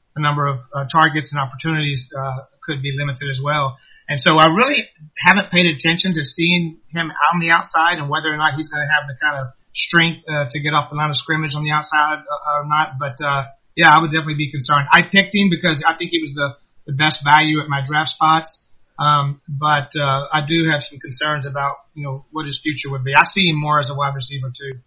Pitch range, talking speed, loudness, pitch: 140-160 Hz, 240 wpm, -17 LUFS, 150 Hz